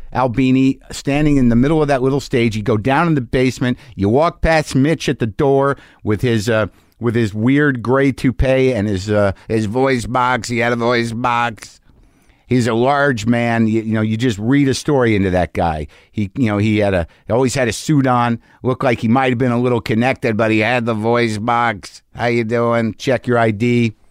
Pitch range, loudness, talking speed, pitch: 110-130 Hz, -16 LUFS, 220 wpm, 120 Hz